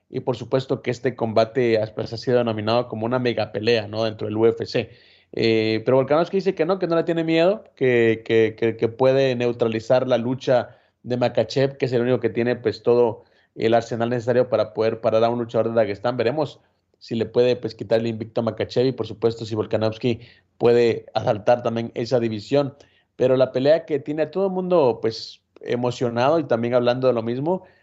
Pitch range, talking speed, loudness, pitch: 115-130 Hz, 200 wpm, -22 LUFS, 120 Hz